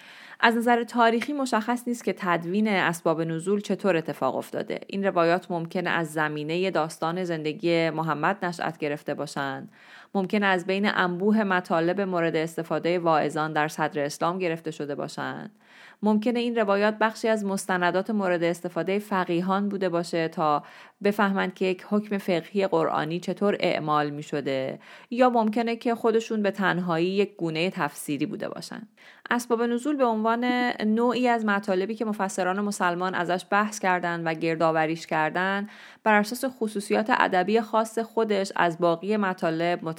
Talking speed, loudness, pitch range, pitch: 145 wpm, -26 LUFS, 165-210 Hz, 185 Hz